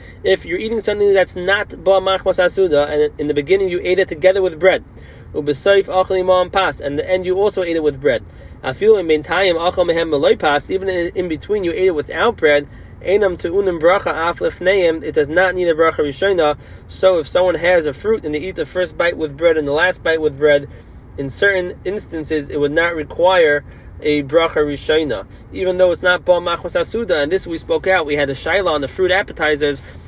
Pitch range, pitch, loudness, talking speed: 150-190 Hz, 170 Hz, -16 LUFS, 185 wpm